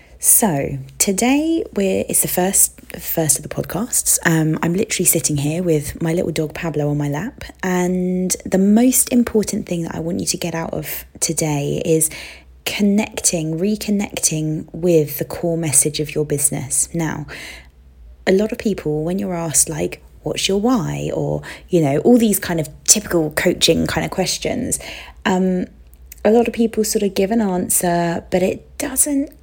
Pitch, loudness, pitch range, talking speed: 170 Hz, -18 LUFS, 155-205 Hz, 170 wpm